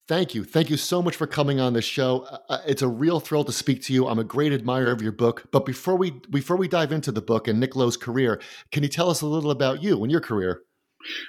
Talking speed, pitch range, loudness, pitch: 265 wpm, 125-160 Hz, -24 LUFS, 135 Hz